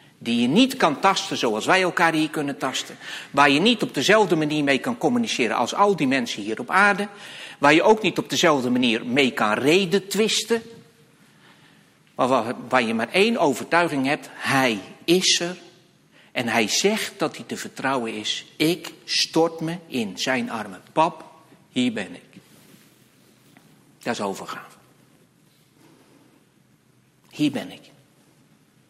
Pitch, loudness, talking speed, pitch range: 175 Hz, -21 LUFS, 150 wpm, 145-210 Hz